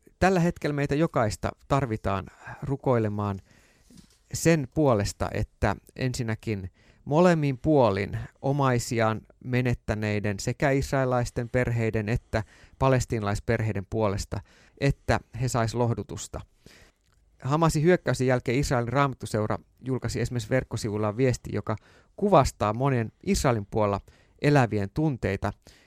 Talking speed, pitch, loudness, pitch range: 95 wpm, 120 Hz, -27 LUFS, 105-135 Hz